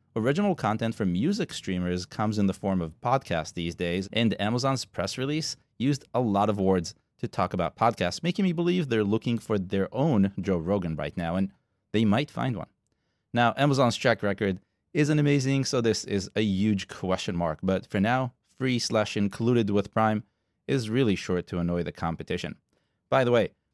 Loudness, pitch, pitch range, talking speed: -27 LUFS, 105 Hz, 95-120 Hz, 185 wpm